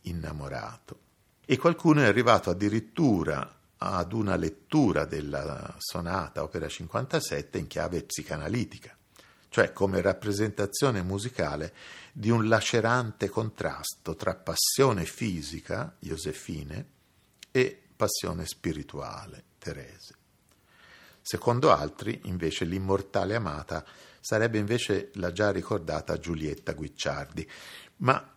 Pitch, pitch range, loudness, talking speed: 100 Hz, 90-115 Hz, -29 LUFS, 95 wpm